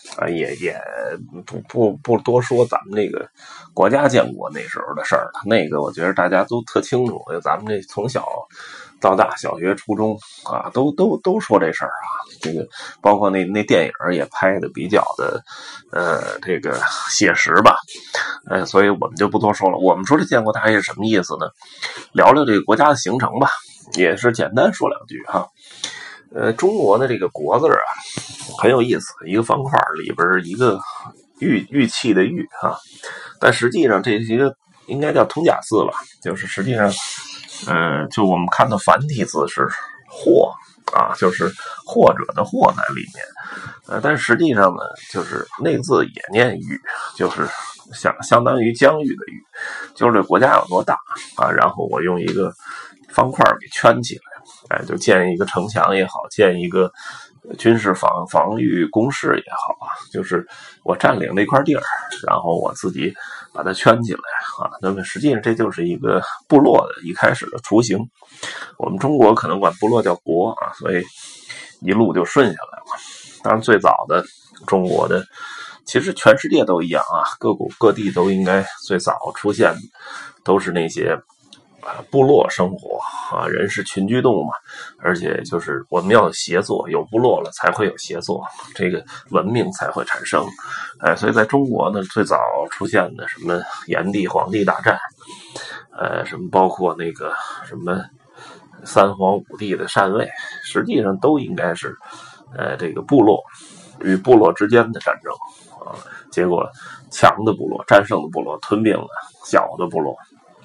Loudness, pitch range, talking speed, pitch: -18 LUFS, 95-125 Hz, 245 characters per minute, 105 Hz